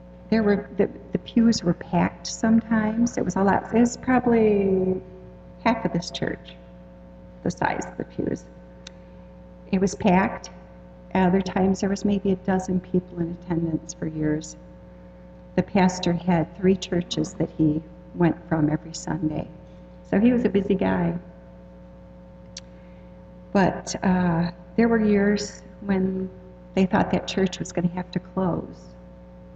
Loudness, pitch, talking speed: -24 LUFS, 175 Hz, 145 wpm